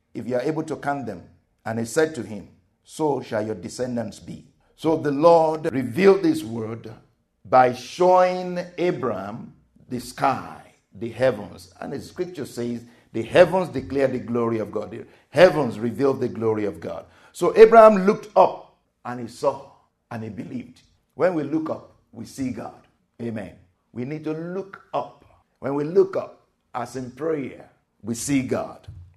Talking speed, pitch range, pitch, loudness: 165 wpm, 115-160 Hz, 125 Hz, -22 LUFS